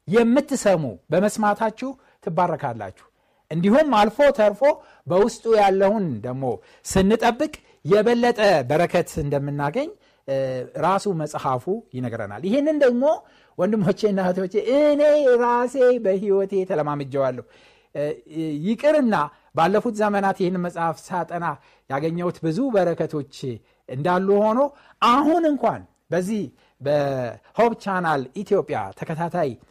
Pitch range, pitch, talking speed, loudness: 150-230 Hz, 190 Hz, 85 wpm, -21 LUFS